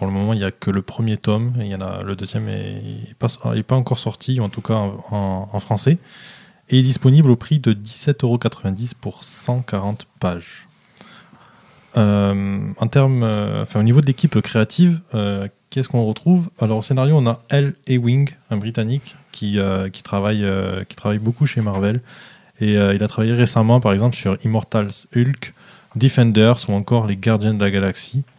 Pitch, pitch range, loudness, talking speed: 115 Hz, 105-130 Hz, -19 LUFS, 190 wpm